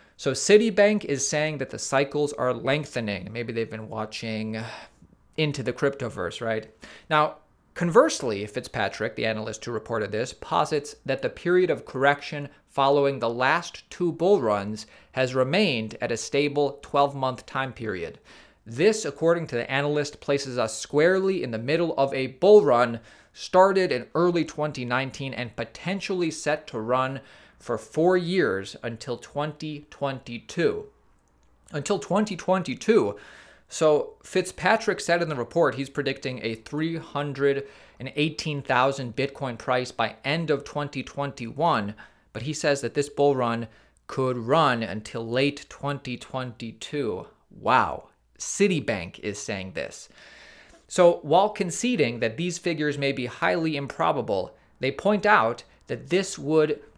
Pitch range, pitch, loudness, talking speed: 120-160 Hz, 140 Hz, -25 LUFS, 135 wpm